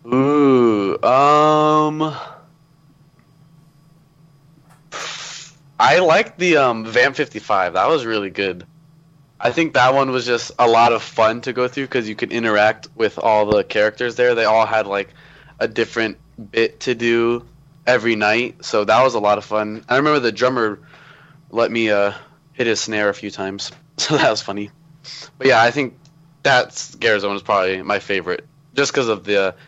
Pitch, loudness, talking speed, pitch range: 125 Hz, -17 LUFS, 170 wpm, 110-155 Hz